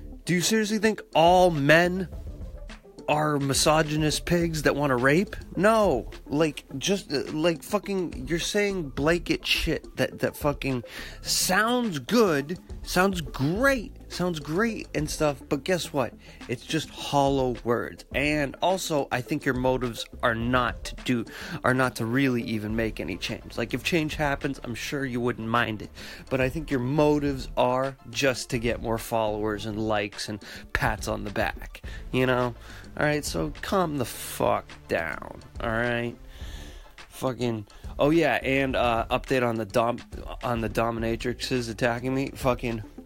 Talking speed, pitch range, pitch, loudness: 155 wpm, 115-155 Hz, 130 Hz, -26 LUFS